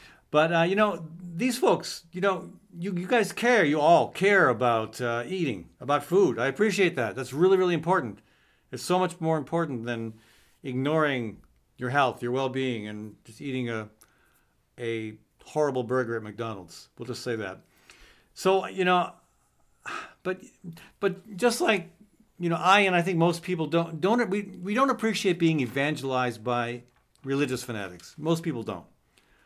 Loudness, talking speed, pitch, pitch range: -26 LUFS, 165 wpm, 155 Hz, 120-185 Hz